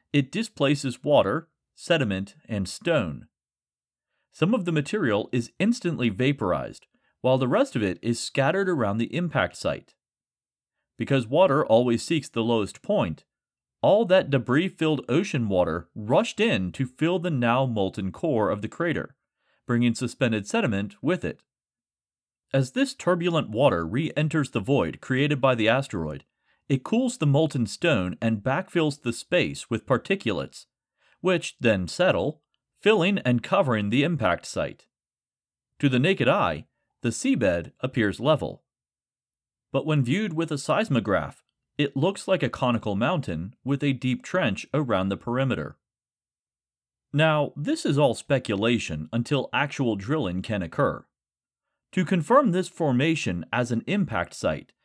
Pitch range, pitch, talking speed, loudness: 115-160 Hz, 135 Hz, 140 wpm, -25 LUFS